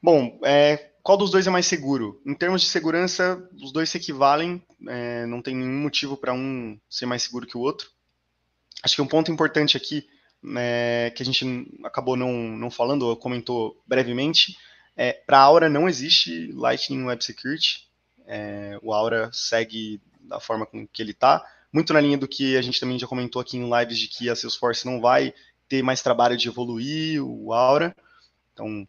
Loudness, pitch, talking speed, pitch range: -22 LUFS, 130 Hz, 190 wpm, 120-150 Hz